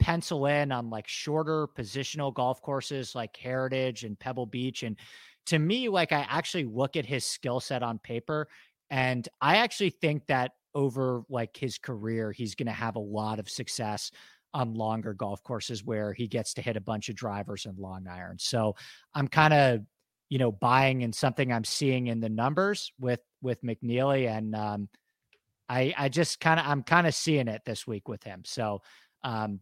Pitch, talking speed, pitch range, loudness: 125 Hz, 190 wpm, 110-140 Hz, -30 LUFS